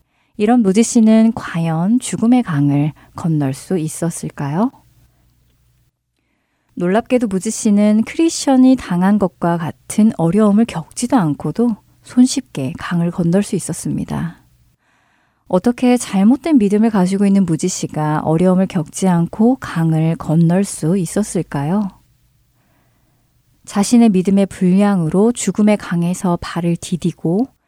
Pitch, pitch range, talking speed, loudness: 190 Hz, 165-220 Hz, 260 characters per minute, -16 LUFS